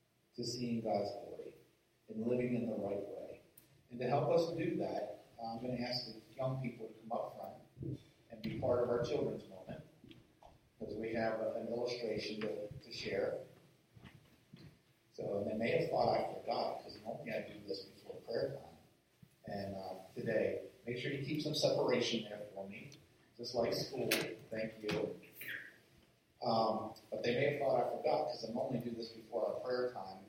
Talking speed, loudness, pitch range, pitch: 185 wpm, -39 LUFS, 110-125 Hz, 120 Hz